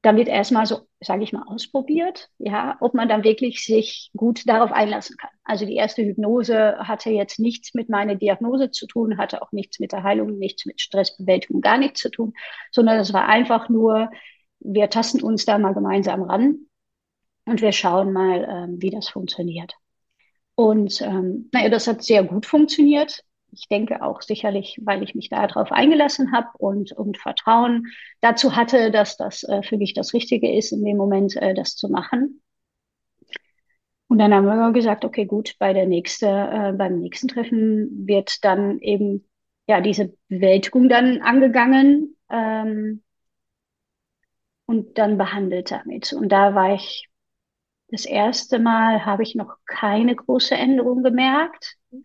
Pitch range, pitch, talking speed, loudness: 200-245 Hz, 220 Hz, 160 wpm, -20 LUFS